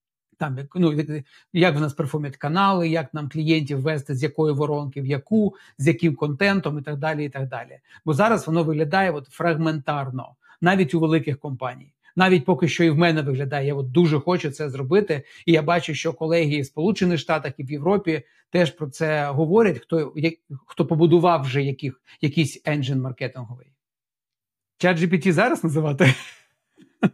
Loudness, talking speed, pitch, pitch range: -22 LUFS, 165 wpm, 155 Hz, 140-170 Hz